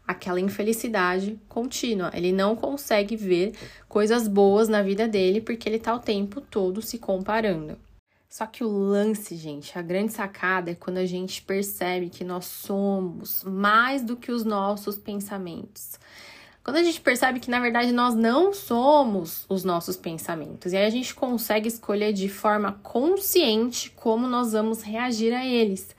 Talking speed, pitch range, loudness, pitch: 160 wpm, 190-235 Hz, -25 LUFS, 210 Hz